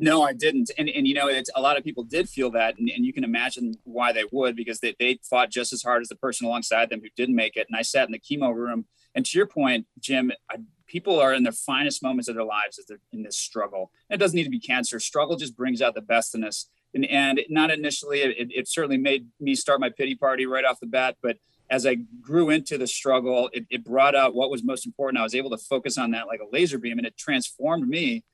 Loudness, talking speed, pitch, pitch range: -24 LUFS, 275 wpm, 130 Hz, 120-145 Hz